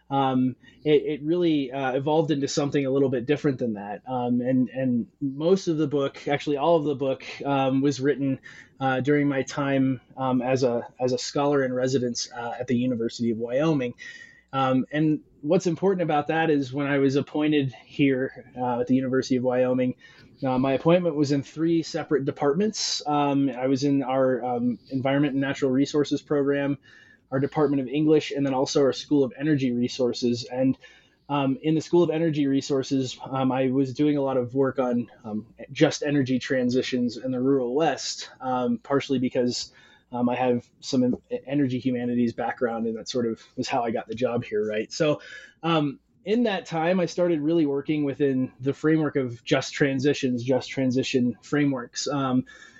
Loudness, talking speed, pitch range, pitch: -25 LUFS, 185 wpm, 125-145 Hz, 135 Hz